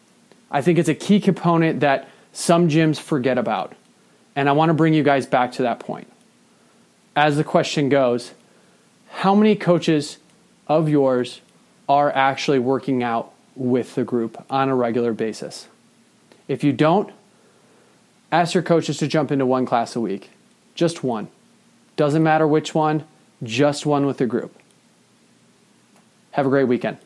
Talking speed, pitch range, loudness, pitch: 155 wpm, 135-170 Hz, -20 LUFS, 150 Hz